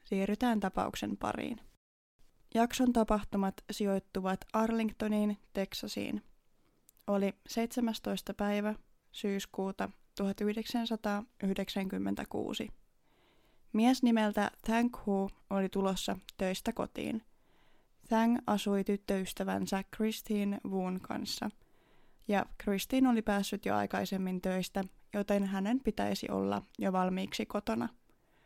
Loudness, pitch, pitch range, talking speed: -34 LUFS, 205 Hz, 195-225 Hz, 85 wpm